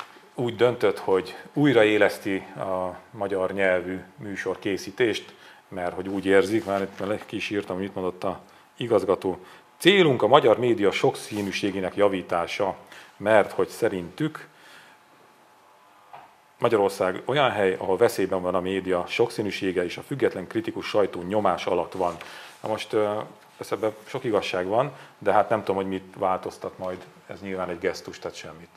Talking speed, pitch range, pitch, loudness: 140 wpm, 90-105 Hz, 95 Hz, -25 LUFS